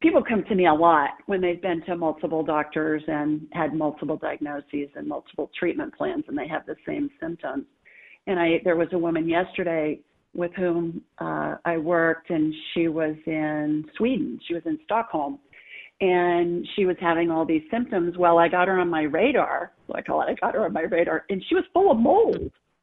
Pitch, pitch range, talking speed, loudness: 170 Hz, 160-210 Hz, 200 wpm, -24 LUFS